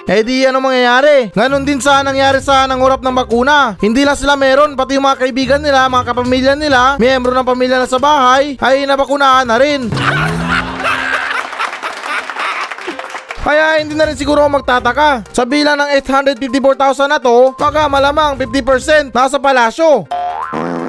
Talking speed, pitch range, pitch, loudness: 145 wpm, 255-285 Hz, 270 Hz, -11 LUFS